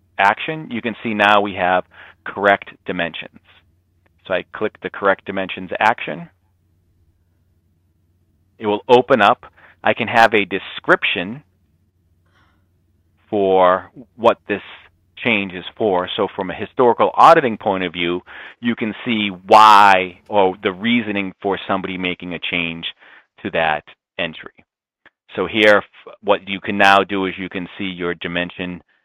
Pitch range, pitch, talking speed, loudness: 85-100 Hz, 95 Hz, 140 wpm, -17 LUFS